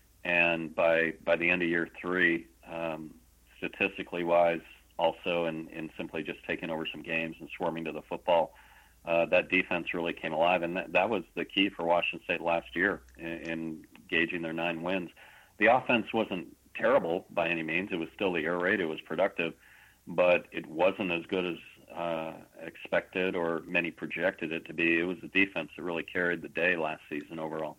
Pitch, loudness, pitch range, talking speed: 85 Hz, -30 LUFS, 80-85 Hz, 195 wpm